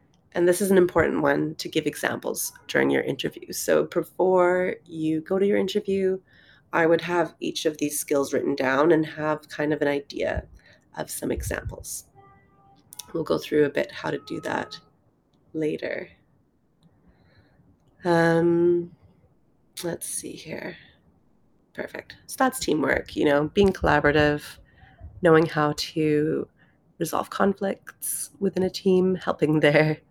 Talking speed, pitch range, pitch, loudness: 140 wpm, 150-180 Hz, 160 Hz, -24 LUFS